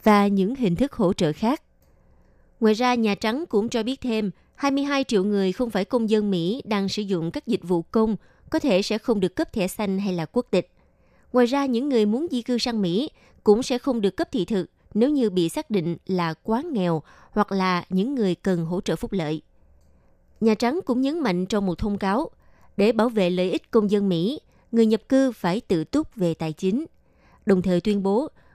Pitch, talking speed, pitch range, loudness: 210 Hz, 220 wpm, 185-240 Hz, -24 LUFS